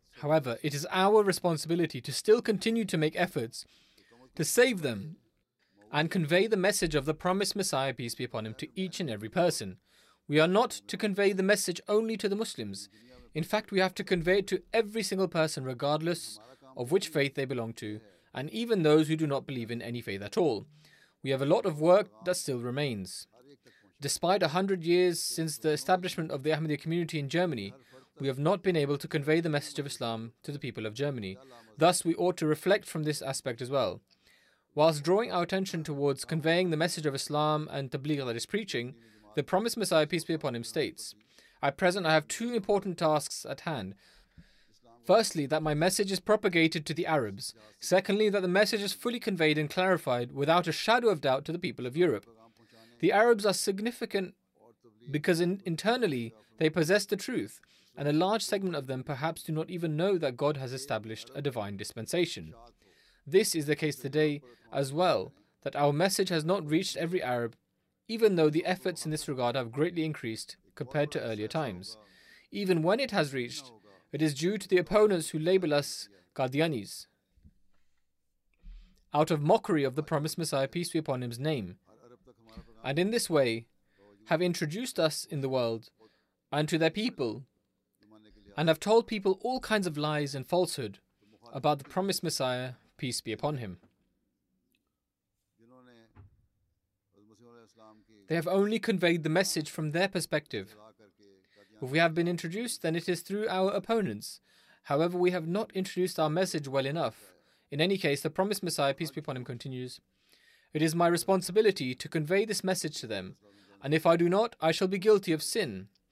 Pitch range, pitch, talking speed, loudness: 125-185 Hz, 155 Hz, 185 wpm, -30 LUFS